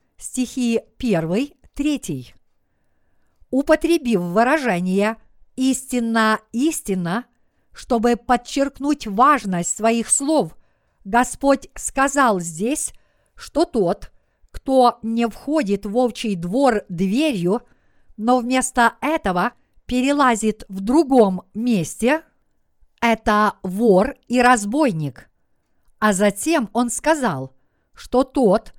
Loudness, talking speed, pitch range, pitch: -20 LUFS, 85 wpm, 210-270 Hz, 240 Hz